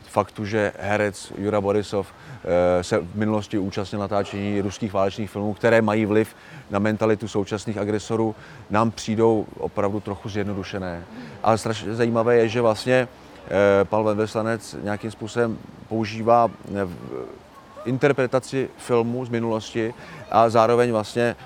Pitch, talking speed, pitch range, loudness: 110 Hz, 120 wpm, 100-115 Hz, -23 LUFS